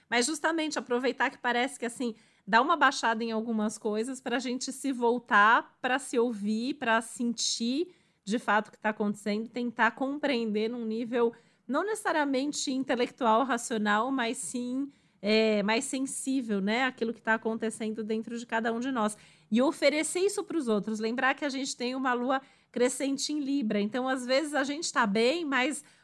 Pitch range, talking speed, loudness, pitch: 225-270 Hz, 175 wpm, -29 LUFS, 245 Hz